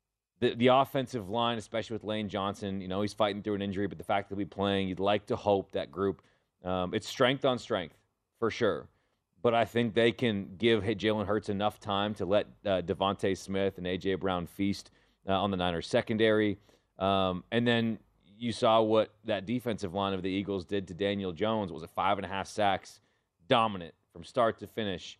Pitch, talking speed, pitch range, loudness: 100 Hz, 210 wpm, 95-110 Hz, -31 LUFS